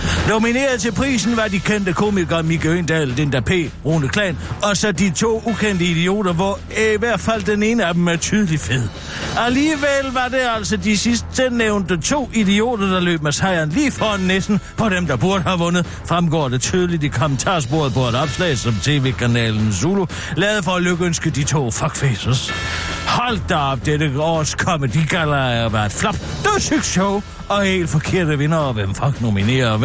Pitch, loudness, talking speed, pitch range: 175 Hz, -18 LUFS, 185 wpm, 145-210 Hz